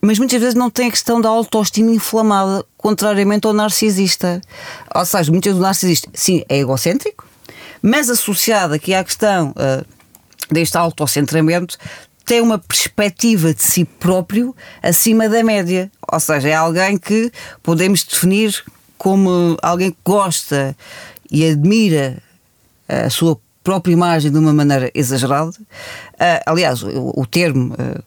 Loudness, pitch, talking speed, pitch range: -15 LUFS, 185 Hz, 140 wpm, 160-215 Hz